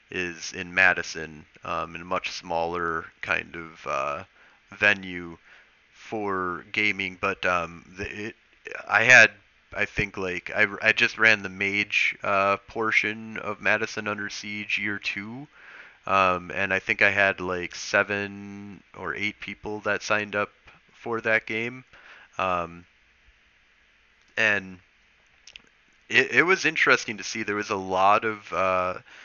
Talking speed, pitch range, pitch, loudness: 140 wpm, 90-105 Hz, 100 Hz, -24 LUFS